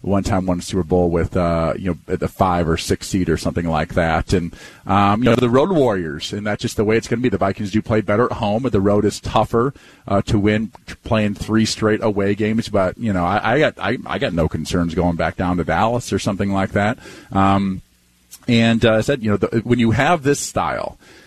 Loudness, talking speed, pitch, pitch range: -18 LUFS, 250 wpm, 100 Hz, 90-110 Hz